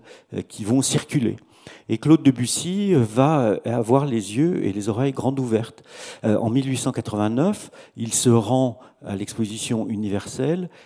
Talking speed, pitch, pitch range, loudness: 125 wpm, 125 Hz, 110-135 Hz, -22 LUFS